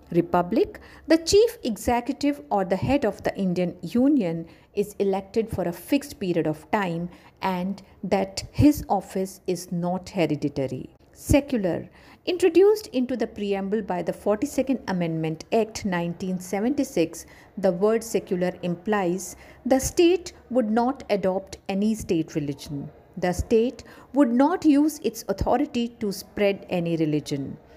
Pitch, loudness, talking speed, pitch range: 200 Hz, -25 LUFS, 130 wpm, 175-255 Hz